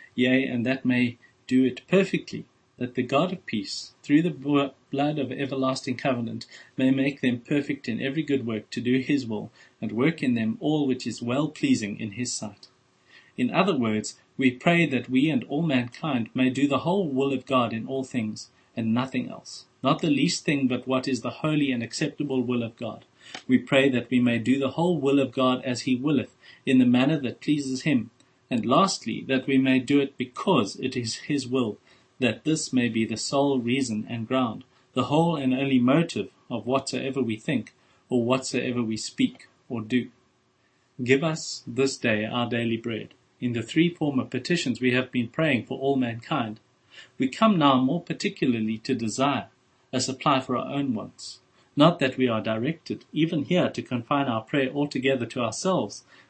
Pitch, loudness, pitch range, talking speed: 130 Hz, -25 LUFS, 125-140 Hz, 195 wpm